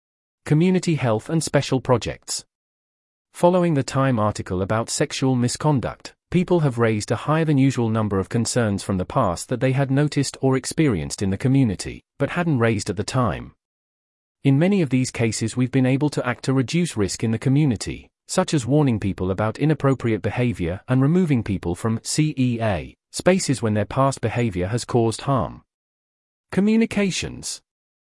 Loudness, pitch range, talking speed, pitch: -21 LUFS, 100-145 Hz, 165 wpm, 120 Hz